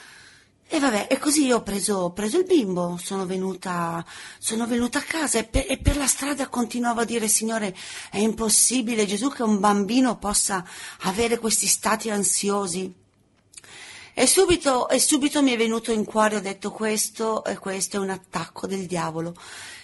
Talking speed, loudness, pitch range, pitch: 170 wpm, -23 LUFS, 195-245 Hz, 215 Hz